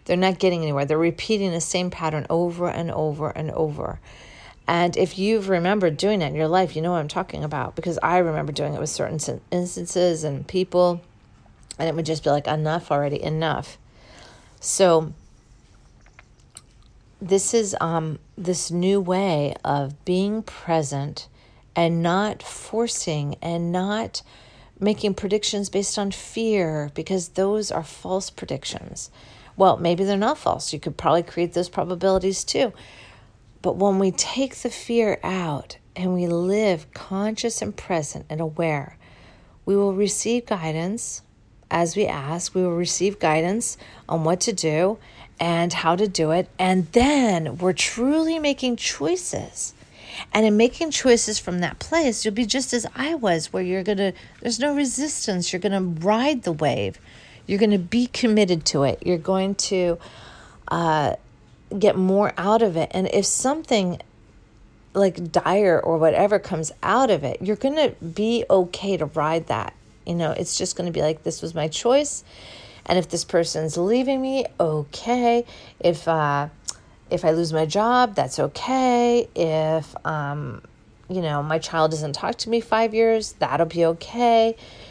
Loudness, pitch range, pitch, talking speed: -22 LUFS, 155-210 Hz, 180 Hz, 165 wpm